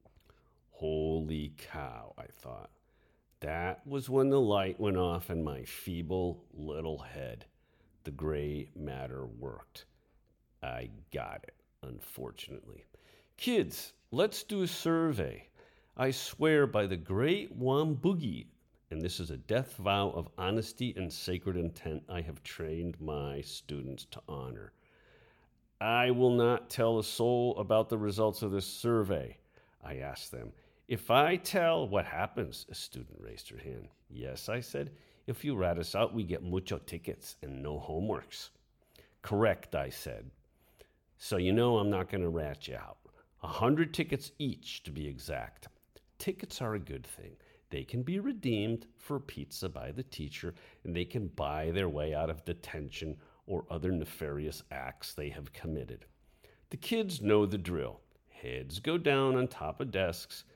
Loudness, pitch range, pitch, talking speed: -34 LUFS, 80-120 Hz, 95 Hz, 155 wpm